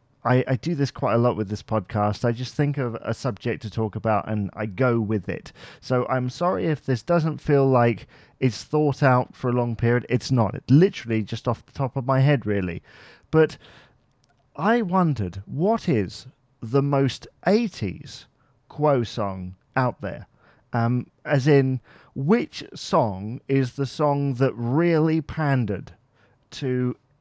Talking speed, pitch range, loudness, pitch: 165 wpm, 115-140 Hz, -23 LUFS, 125 Hz